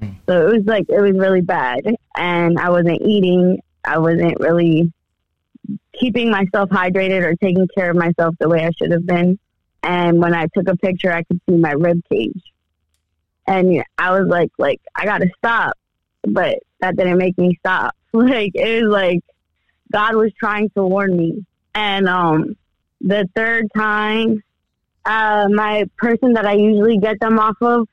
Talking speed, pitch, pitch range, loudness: 170 wpm, 190 Hz, 175-215 Hz, -16 LUFS